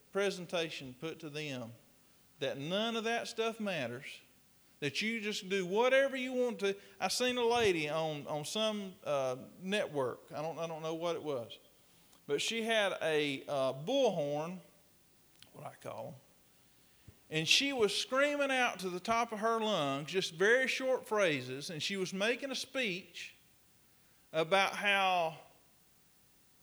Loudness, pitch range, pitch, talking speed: -34 LUFS, 155-225 Hz, 190 Hz, 155 wpm